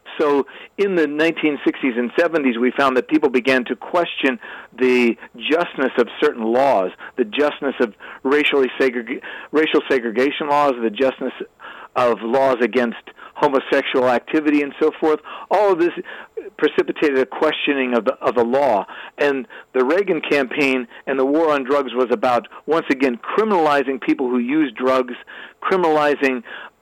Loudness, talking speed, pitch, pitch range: -19 LUFS, 150 wpm, 140 Hz, 125-155 Hz